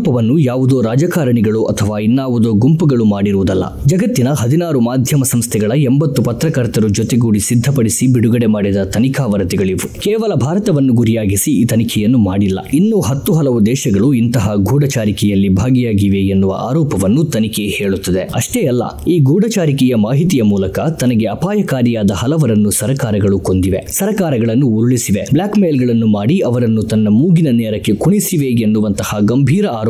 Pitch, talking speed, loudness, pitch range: 120 Hz, 120 wpm, -13 LUFS, 105-140 Hz